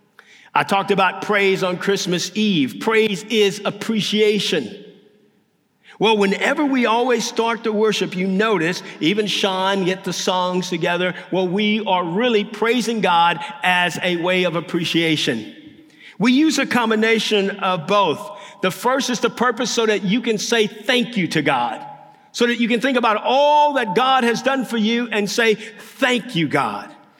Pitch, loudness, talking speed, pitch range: 210 Hz, -18 LUFS, 165 wpm, 185-235 Hz